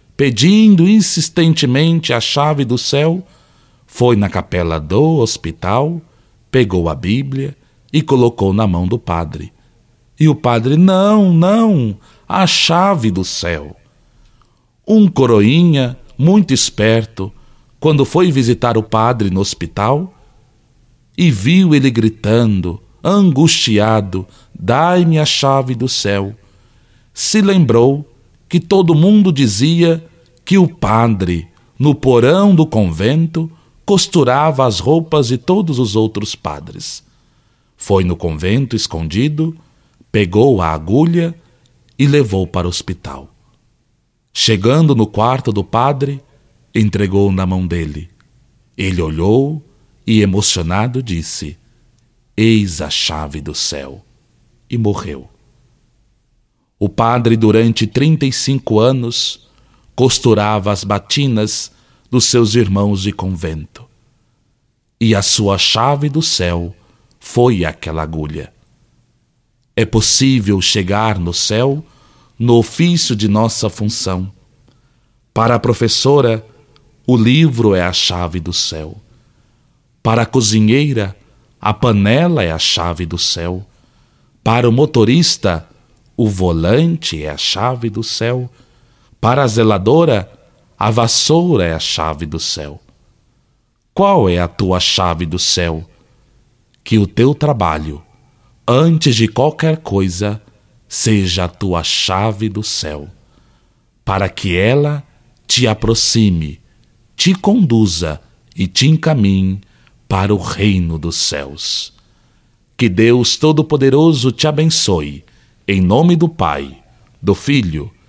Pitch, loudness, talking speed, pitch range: 115 Hz, -13 LUFS, 115 wpm, 100-135 Hz